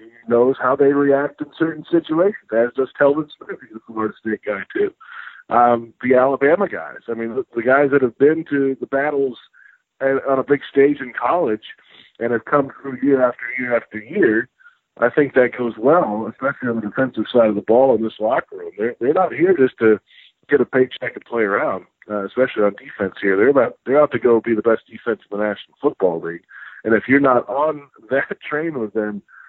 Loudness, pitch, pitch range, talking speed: -18 LUFS, 130 Hz, 115-145 Hz, 215 wpm